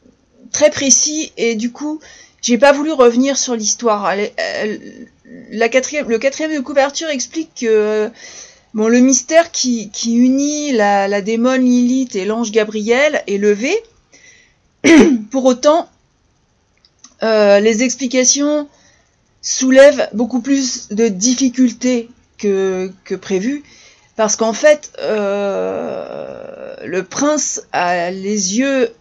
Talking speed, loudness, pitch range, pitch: 120 wpm, -14 LUFS, 220-290 Hz, 255 Hz